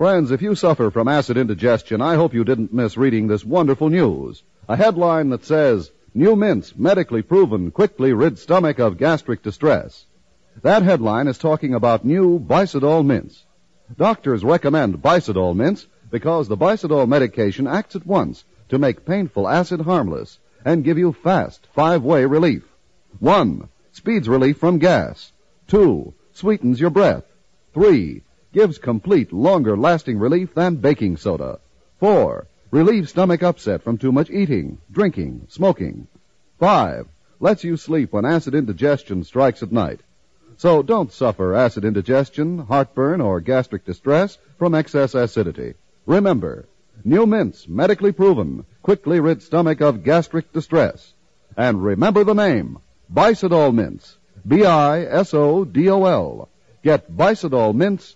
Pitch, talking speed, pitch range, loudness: 155 Hz, 135 wpm, 125-180 Hz, -18 LUFS